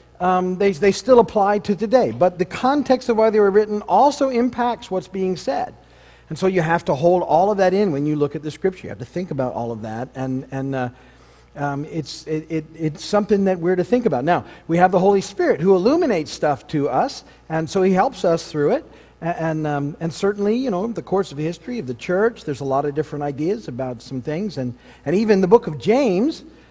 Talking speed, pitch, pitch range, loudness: 240 wpm, 180 Hz, 150-205 Hz, -20 LUFS